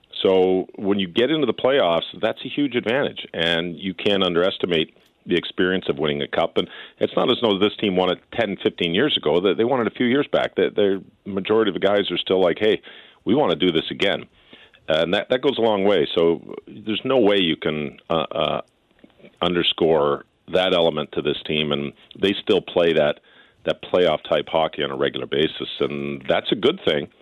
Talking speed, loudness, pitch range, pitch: 215 wpm, -21 LUFS, 85-100 Hz, 95 Hz